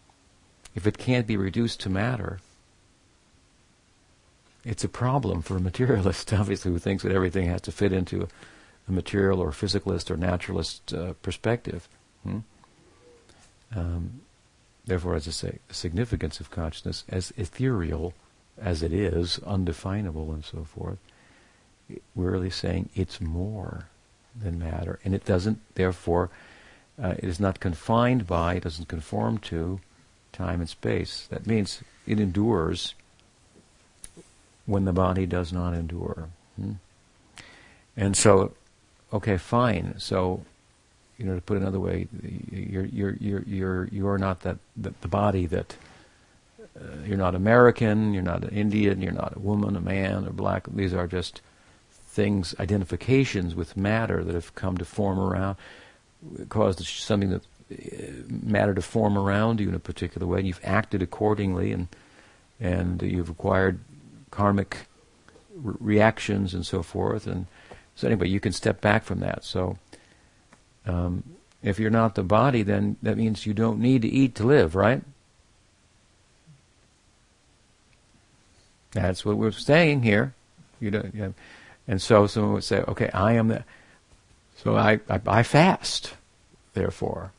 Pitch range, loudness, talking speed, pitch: 90-105 Hz, -26 LUFS, 150 wpm, 100 Hz